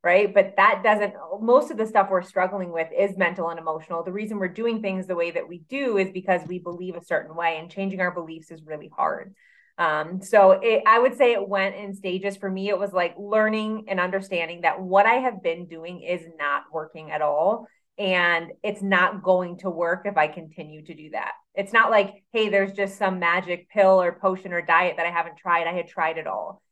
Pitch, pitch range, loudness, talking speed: 185 Hz, 170-200 Hz, -23 LUFS, 230 wpm